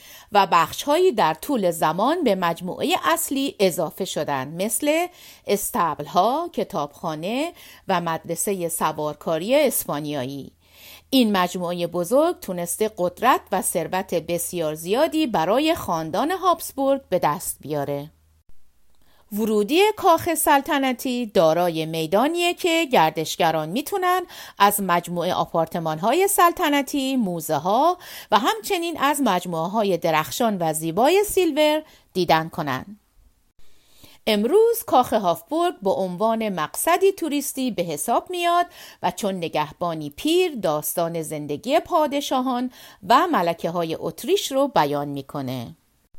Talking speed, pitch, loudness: 110 wpm, 200 Hz, -22 LUFS